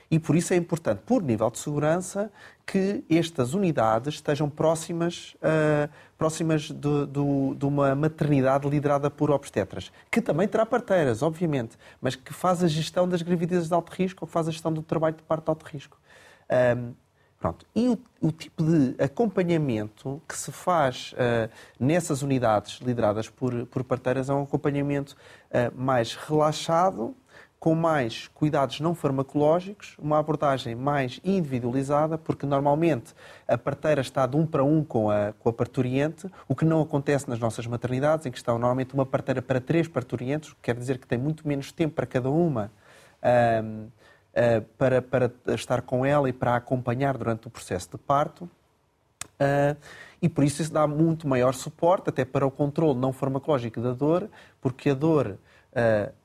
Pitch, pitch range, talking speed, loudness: 145 Hz, 130-160 Hz, 170 wpm, -26 LUFS